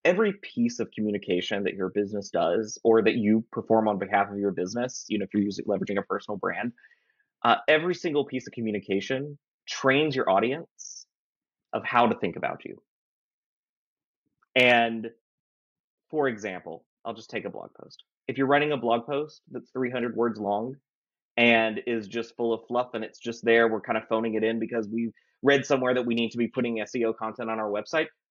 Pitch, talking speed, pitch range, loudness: 115 Hz, 195 wpm, 110-130 Hz, -26 LUFS